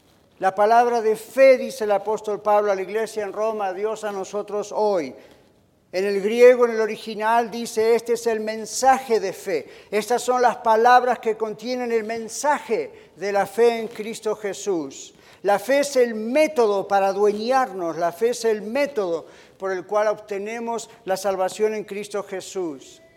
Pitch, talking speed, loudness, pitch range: 220 Hz, 170 wpm, -22 LUFS, 205-240 Hz